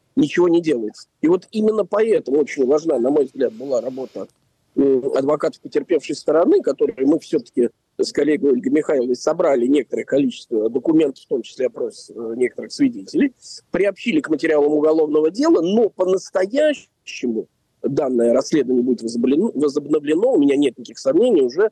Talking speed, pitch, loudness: 140 wpm, 215 Hz, -19 LUFS